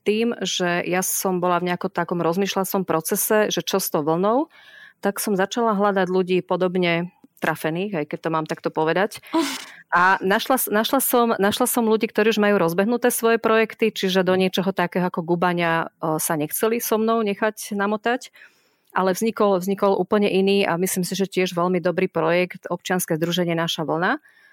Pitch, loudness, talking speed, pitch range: 190 Hz, -21 LUFS, 170 wpm, 175-215 Hz